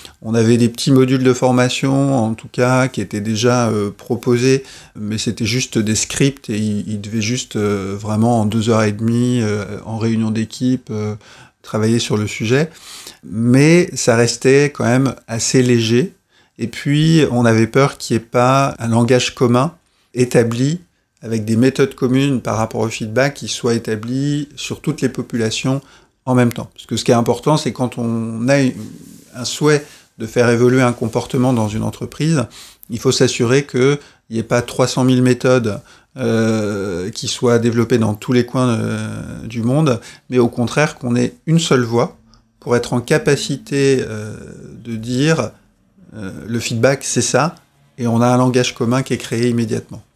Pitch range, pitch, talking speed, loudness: 115-130 Hz, 120 Hz, 180 wpm, -16 LUFS